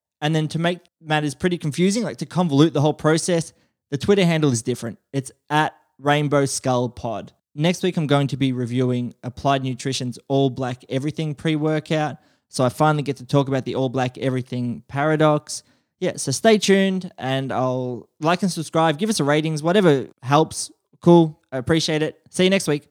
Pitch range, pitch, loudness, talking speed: 130-160 Hz, 150 Hz, -21 LUFS, 190 wpm